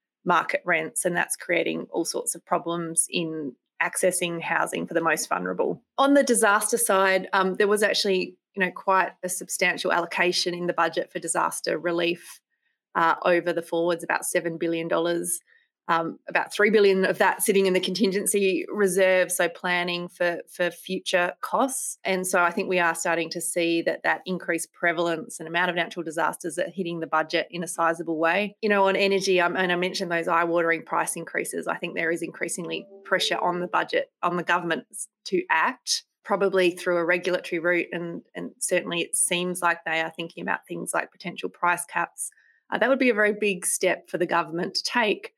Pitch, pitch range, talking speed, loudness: 180 Hz, 170-195 Hz, 195 wpm, -24 LUFS